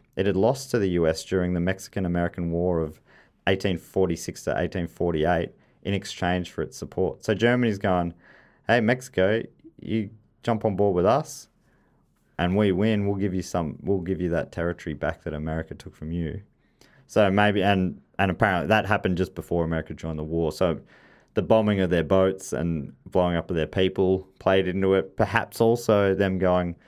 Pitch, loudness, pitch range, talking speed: 95 Hz, -25 LUFS, 85-100 Hz, 180 wpm